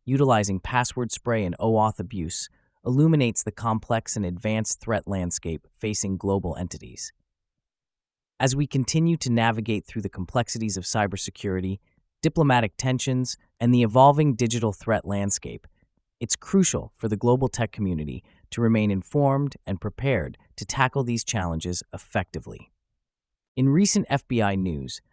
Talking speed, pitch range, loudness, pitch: 130 wpm, 95-125 Hz, -24 LUFS, 110 Hz